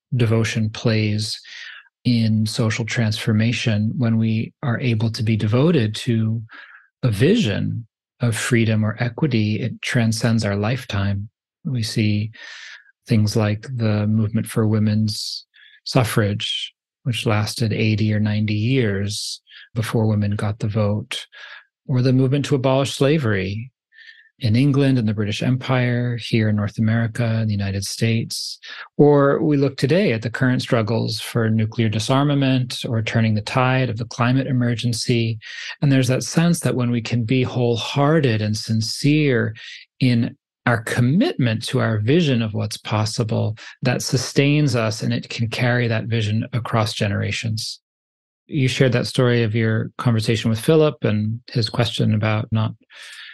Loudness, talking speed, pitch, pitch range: -20 LUFS, 145 wpm, 115 Hz, 110-130 Hz